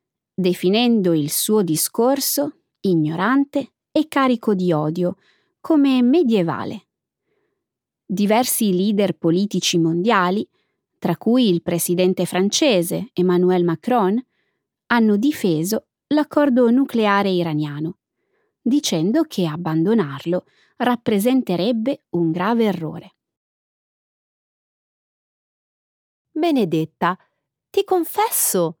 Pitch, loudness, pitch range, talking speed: 200 Hz, -19 LUFS, 175-255 Hz, 75 wpm